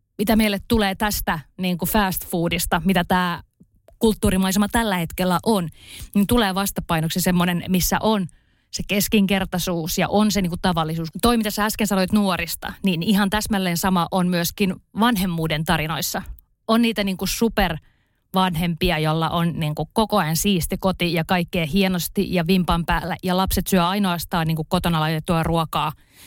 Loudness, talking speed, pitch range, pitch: -21 LUFS, 160 wpm, 170-200 Hz, 185 Hz